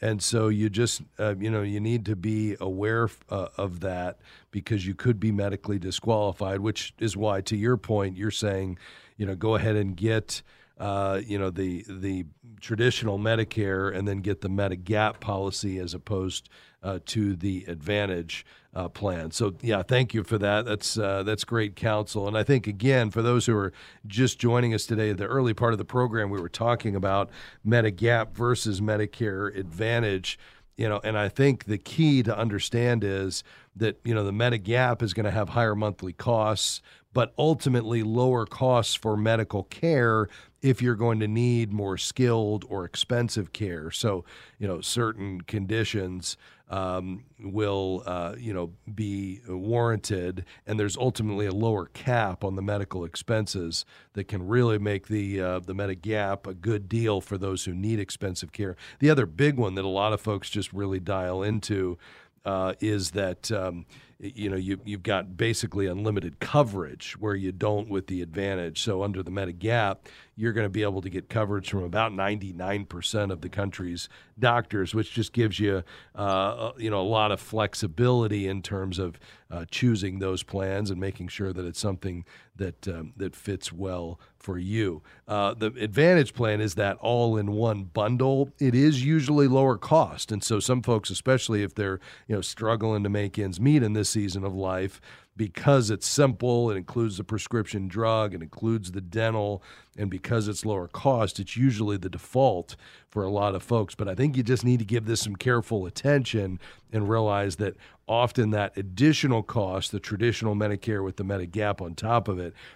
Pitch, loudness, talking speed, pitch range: 105 Hz, -27 LUFS, 180 wpm, 95-115 Hz